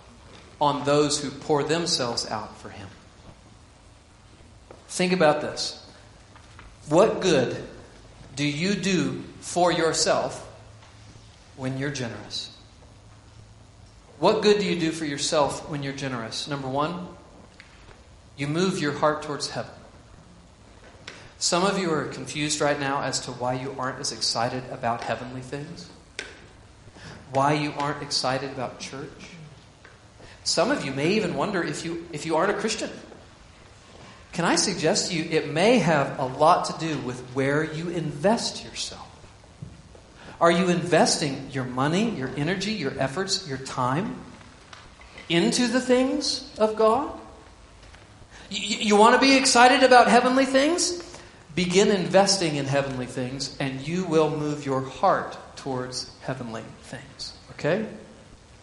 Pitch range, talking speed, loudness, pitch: 115-170 Hz, 135 wpm, -24 LUFS, 140 Hz